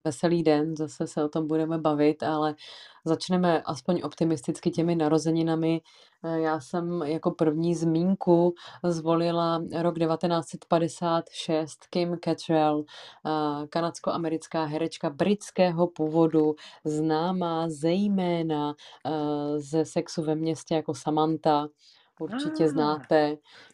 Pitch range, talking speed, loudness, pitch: 155-170 Hz, 95 wpm, -27 LUFS, 160 Hz